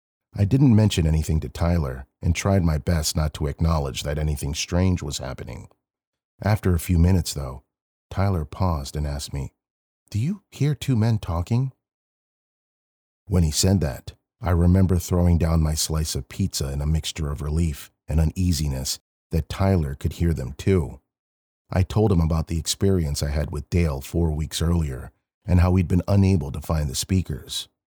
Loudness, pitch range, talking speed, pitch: -23 LUFS, 75-95 Hz, 175 wpm, 85 Hz